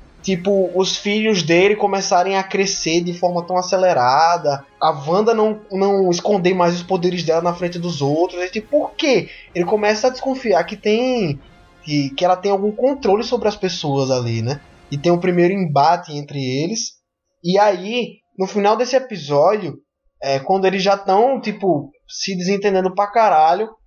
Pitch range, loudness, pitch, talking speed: 170-210 Hz, -18 LUFS, 190 Hz, 175 wpm